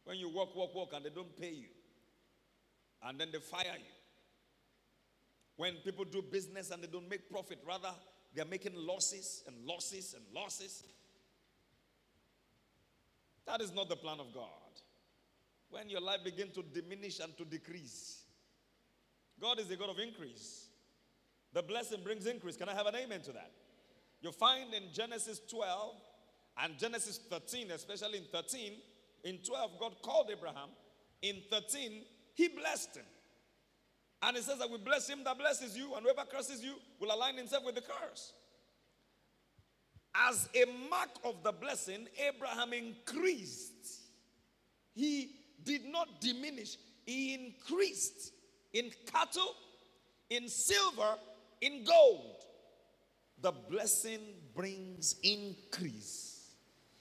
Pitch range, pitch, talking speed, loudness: 185-260 Hz, 215 Hz, 140 wpm, -38 LUFS